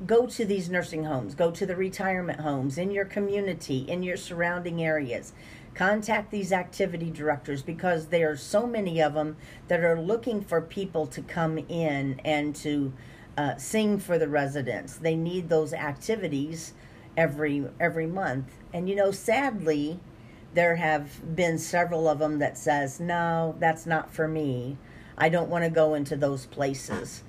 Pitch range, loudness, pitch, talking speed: 150-180 Hz, -28 LUFS, 165 Hz, 165 wpm